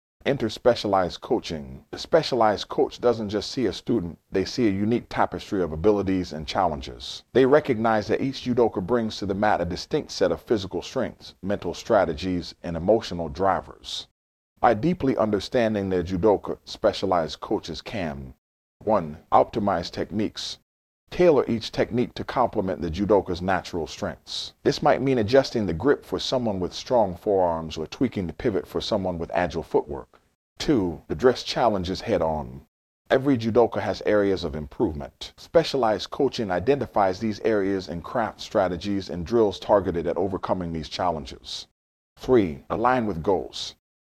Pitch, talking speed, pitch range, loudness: 95 Hz, 150 wpm, 80-110 Hz, -25 LUFS